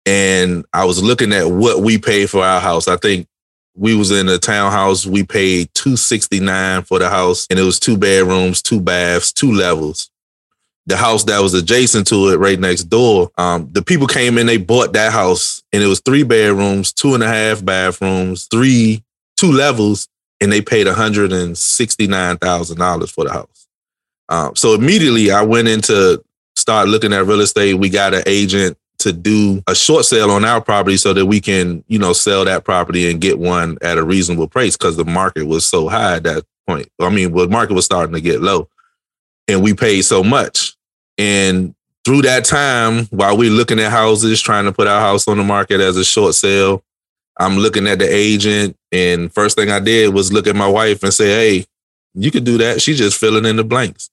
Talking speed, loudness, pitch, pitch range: 205 wpm, -13 LUFS, 100 Hz, 95-110 Hz